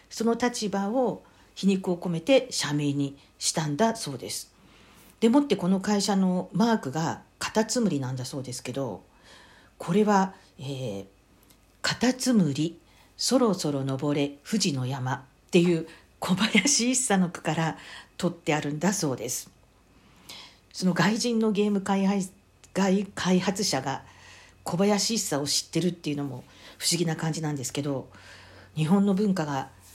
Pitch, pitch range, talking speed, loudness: 170 Hz, 140-205 Hz, 280 characters per minute, -26 LUFS